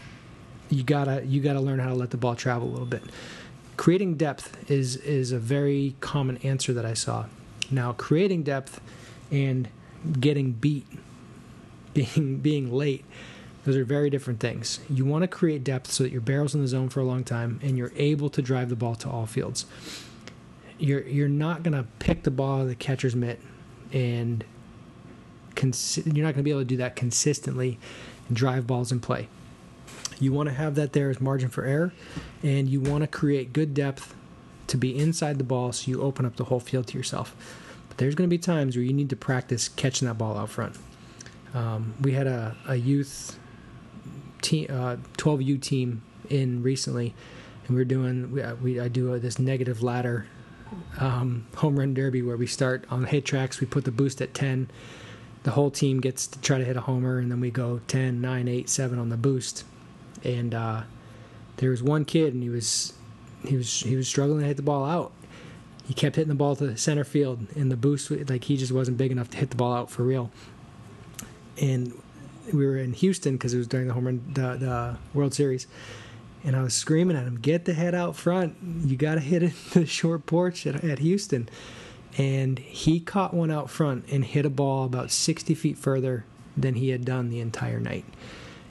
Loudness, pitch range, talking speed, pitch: -27 LUFS, 125-145 Hz, 205 wpm, 130 Hz